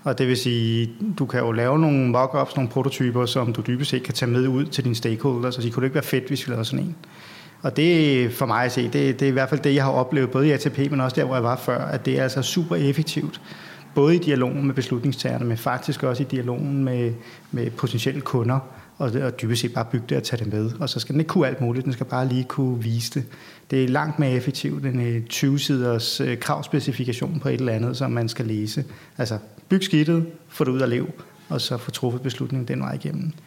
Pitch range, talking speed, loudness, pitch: 125-140 Hz, 250 wpm, -23 LUFS, 130 Hz